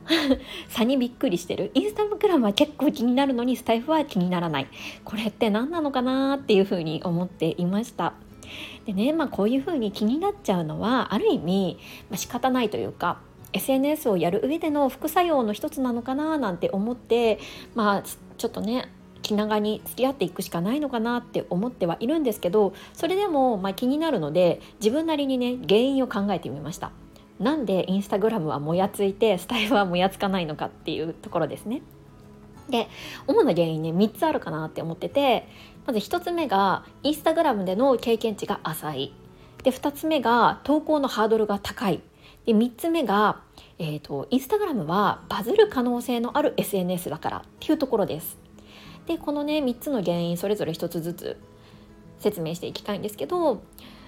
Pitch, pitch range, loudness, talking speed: 225 Hz, 190-275 Hz, -25 LUFS, 380 characters per minute